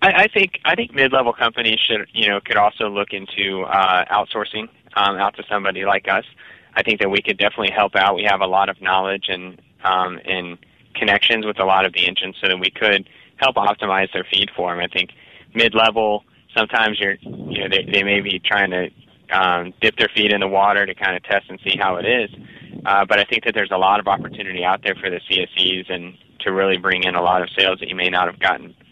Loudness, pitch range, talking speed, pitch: -18 LUFS, 95-110 Hz, 240 wpm, 100 Hz